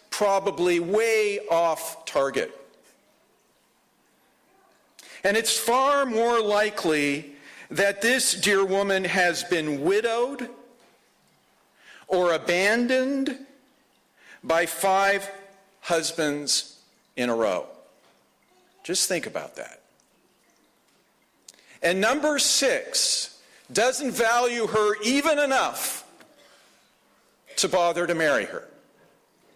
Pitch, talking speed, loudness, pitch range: 210 Hz, 85 wpm, -23 LUFS, 175-260 Hz